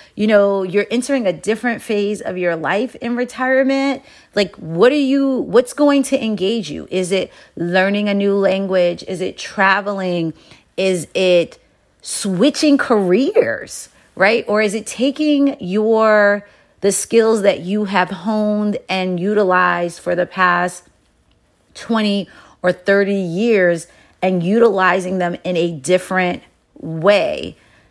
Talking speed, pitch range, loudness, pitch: 135 wpm, 185-230 Hz, -17 LUFS, 200 Hz